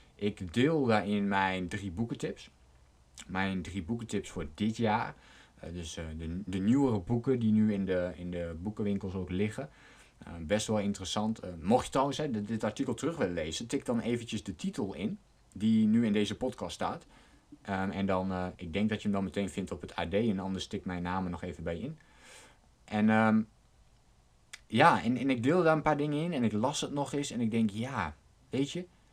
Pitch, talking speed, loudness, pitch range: 105 Hz, 210 wpm, -32 LUFS, 95-115 Hz